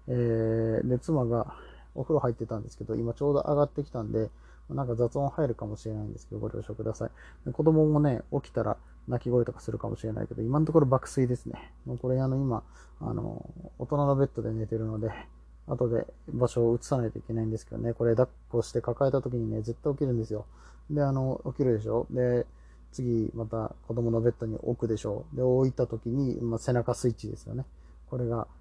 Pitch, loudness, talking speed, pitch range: 120 Hz, -30 LUFS, 410 characters per minute, 110-130 Hz